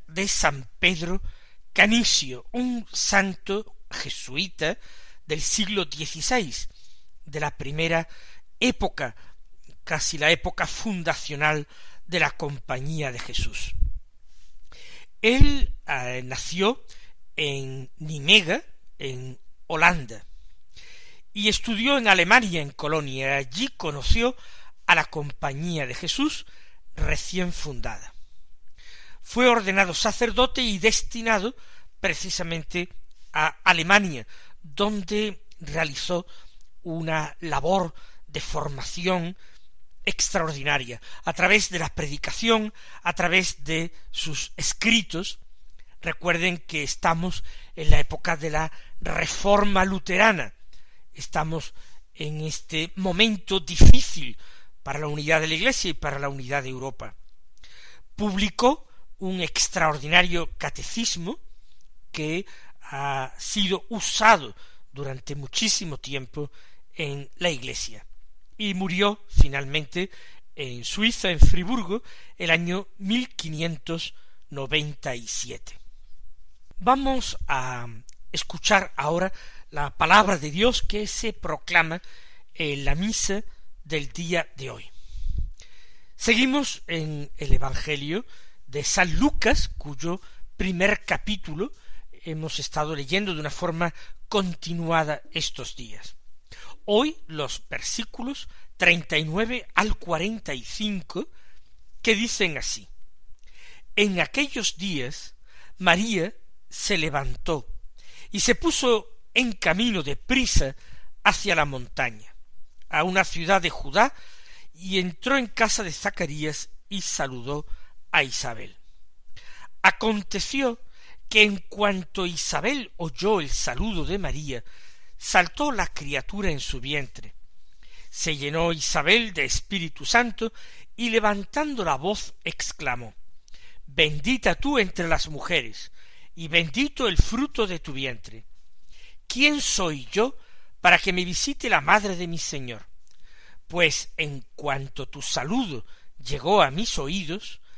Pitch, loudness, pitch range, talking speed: 170 Hz, -24 LUFS, 140-205 Hz, 110 wpm